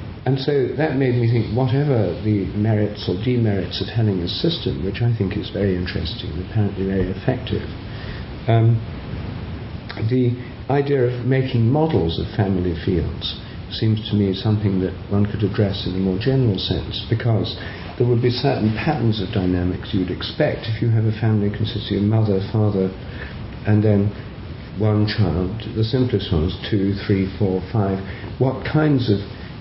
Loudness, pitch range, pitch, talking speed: -21 LUFS, 95-115 Hz, 105 Hz, 160 wpm